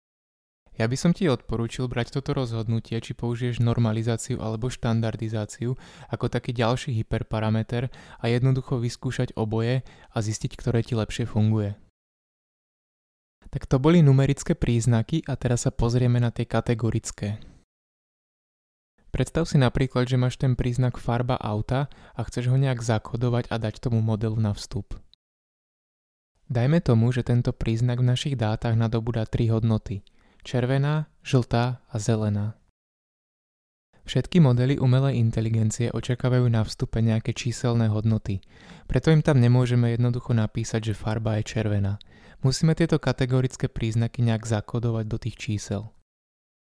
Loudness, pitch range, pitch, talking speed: -25 LUFS, 110-130 Hz, 120 Hz, 135 wpm